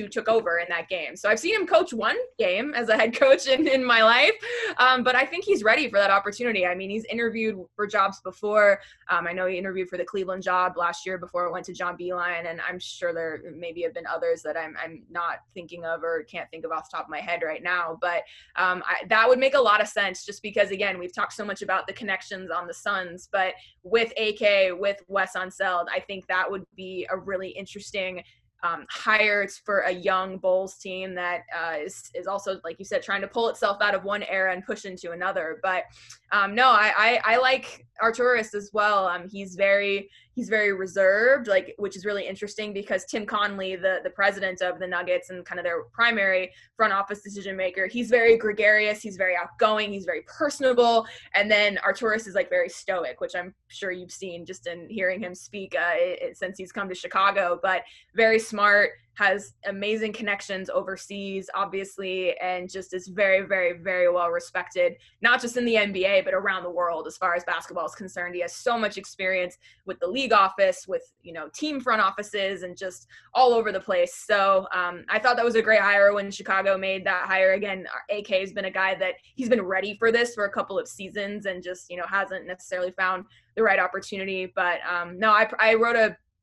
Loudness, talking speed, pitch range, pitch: -24 LUFS, 220 wpm, 185-220 Hz, 195 Hz